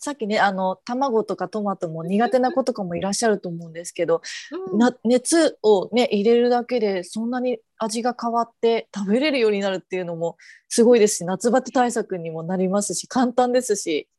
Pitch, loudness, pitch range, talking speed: 220 Hz, -21 LUFS, 190-245 Hz, 390 characters per minute